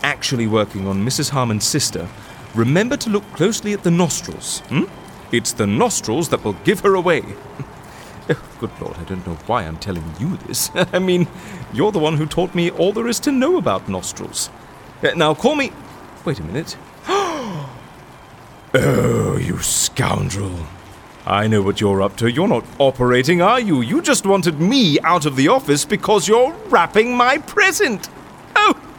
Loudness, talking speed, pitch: -18 LUFS, 165 wpm, 155 Hz